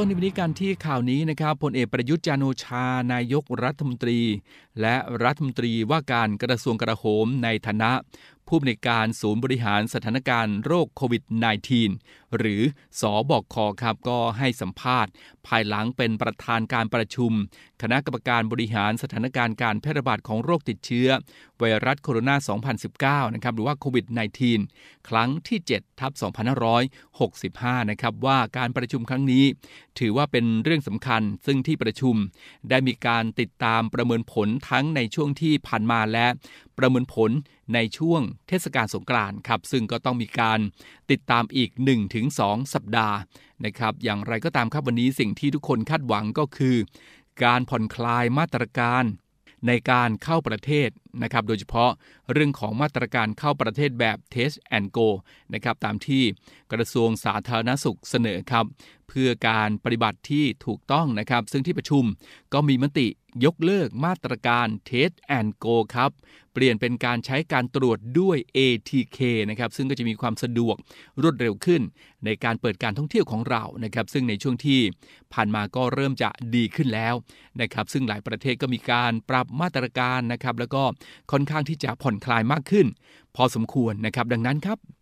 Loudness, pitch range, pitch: -24 LUFS, 115-135 Hz, 120 Hz